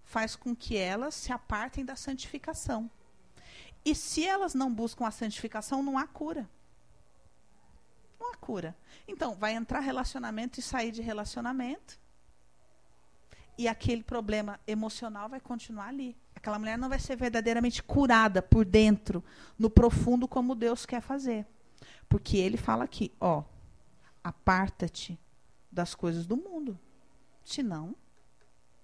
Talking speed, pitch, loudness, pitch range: 130 wpm, 230 Hz, -31 LUFS, 205-260 Hz